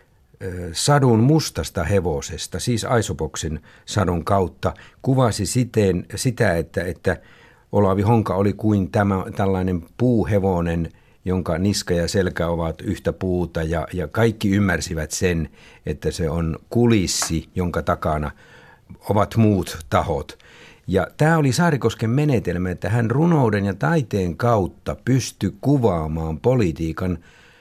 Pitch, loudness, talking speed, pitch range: 100 Hz, -21 LUFS, 115 wpm, 85-115 Hz